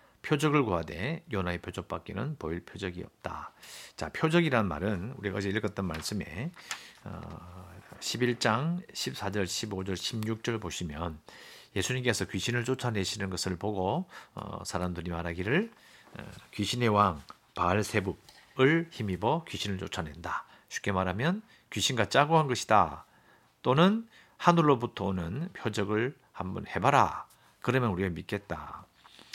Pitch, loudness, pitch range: 105 Hz, -30 LUFS, 95-125 Hz